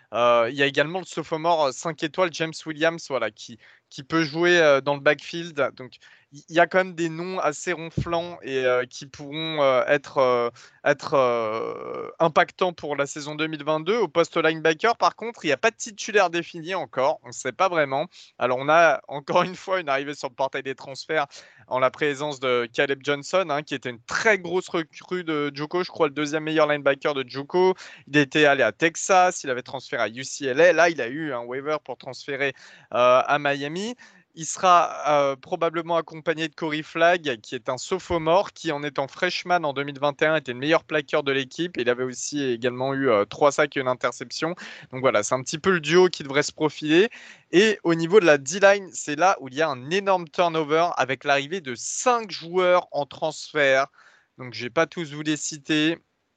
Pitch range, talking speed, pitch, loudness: 140-175 Hz, 205 wpm, 155 Hz, -23 LUFS